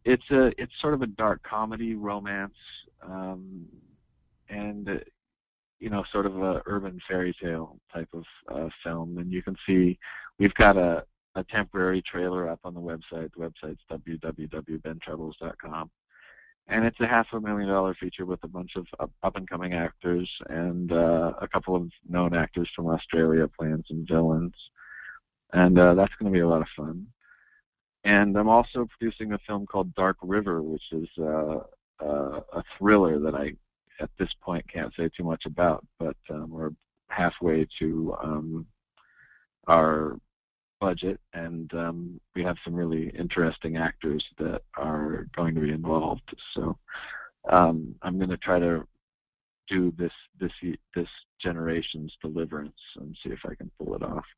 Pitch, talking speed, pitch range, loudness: 85 Hz, 160 wpm, 80-95 Hz, -27 LUFS